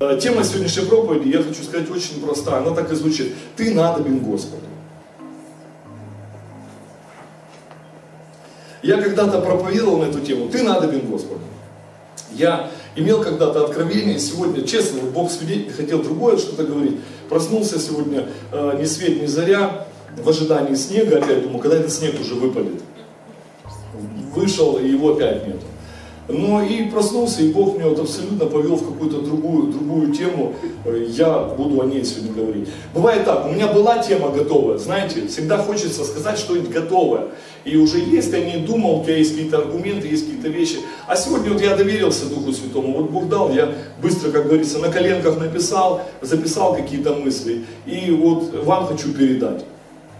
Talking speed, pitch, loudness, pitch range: 155 wpm, 160 Hz, -19 LUFS, 145-195 Hz